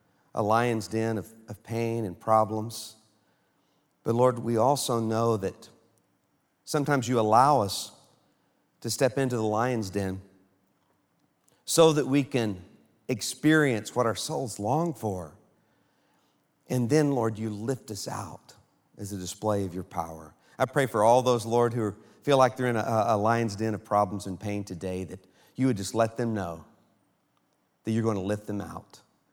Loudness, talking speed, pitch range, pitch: -27 LUFS, 165 wpm, 105-125 Hz, 110 Hz